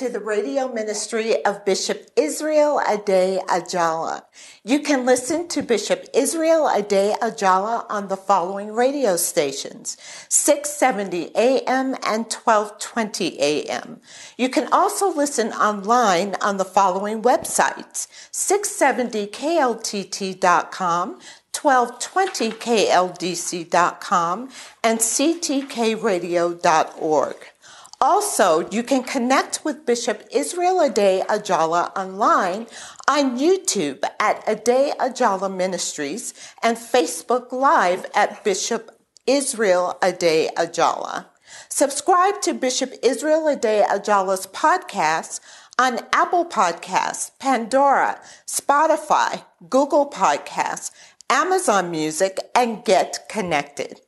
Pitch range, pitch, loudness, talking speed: 195-280 Hz, 230 Hz, -20 LUFS, 90 wpm